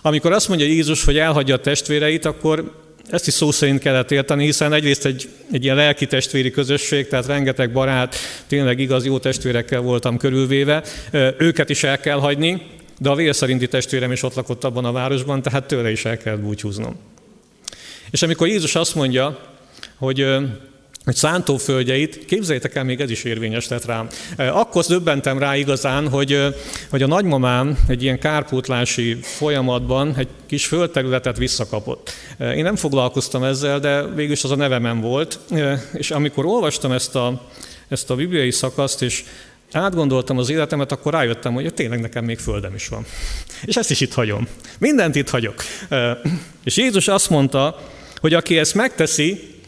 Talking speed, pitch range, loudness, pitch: 160 wpm, 130-150 Hz, -19 LUFS, 140 Hz